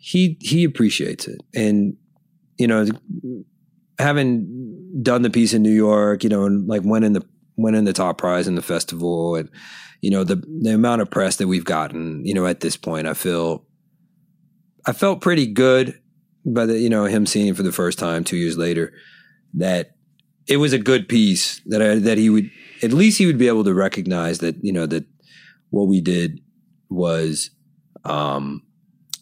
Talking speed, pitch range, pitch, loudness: 190 wpm, 90-150 Hz, 110 Hz, -19 LUFS